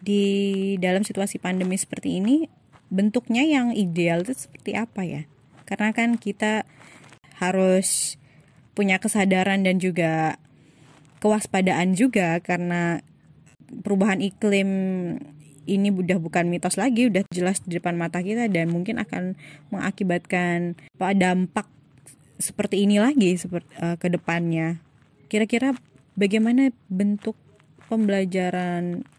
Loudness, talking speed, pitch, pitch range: -23 LUFS, 105 wpm, 185 Hz, 170-205 Hz